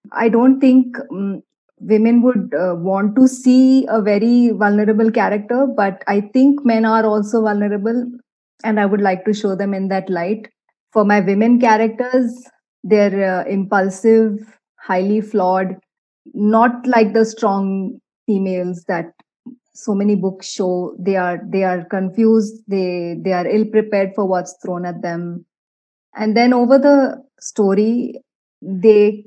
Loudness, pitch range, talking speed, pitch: -16 LUFS, 195-230 Hz, 145 wpm, 210 Hz